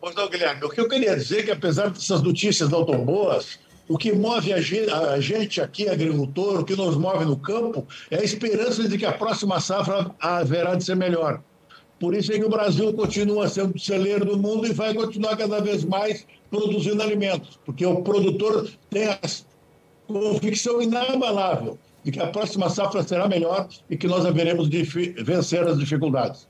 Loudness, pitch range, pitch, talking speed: -23 LUFS, 170-210 Hz, 195 Hz, 185 wpm